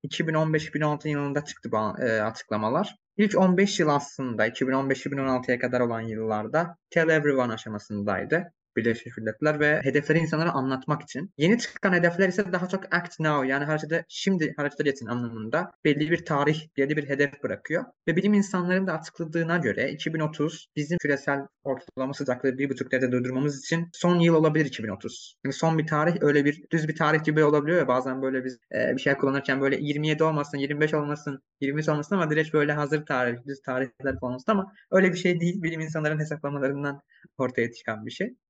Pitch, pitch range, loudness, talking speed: 150 Hz, 135-165 Hz, -26 LUFS, 175 wpm